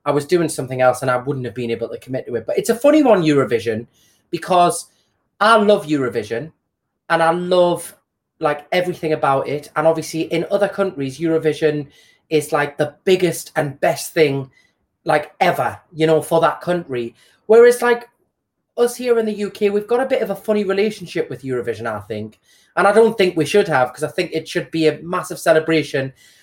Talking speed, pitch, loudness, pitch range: 200 wpm, 165 Hz, -18 LUFS, 145-195 Hz